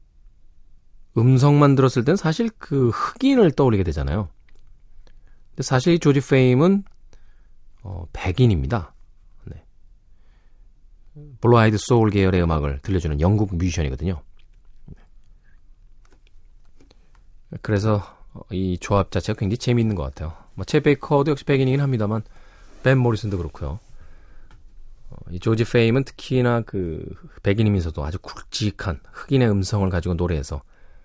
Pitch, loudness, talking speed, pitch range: 105 Hz, -20 LUFS, 280 characters per minute, 85-130 Hz